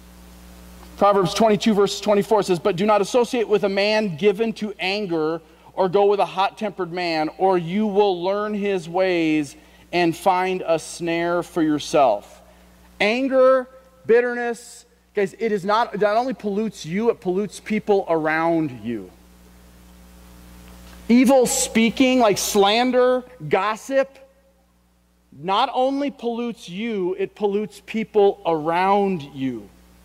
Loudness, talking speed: -20 LUFS, 125 wpm